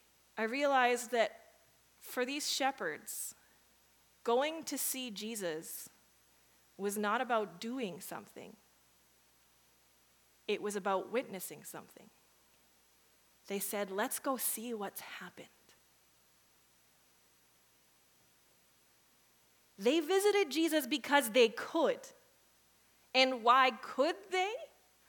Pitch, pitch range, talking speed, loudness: 245 Hz, 205-285 Hz, 90 wpm, -34 LUFS